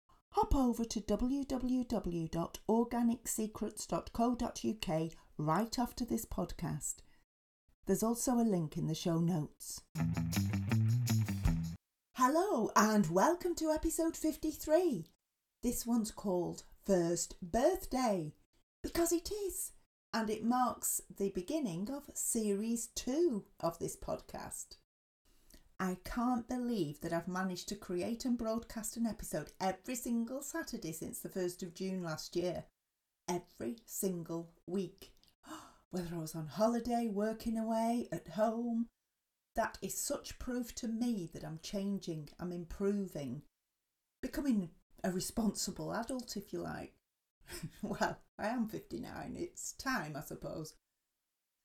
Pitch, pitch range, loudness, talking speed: 205 Hz, 170-240 Hz, -37 LUFS, 115 wpm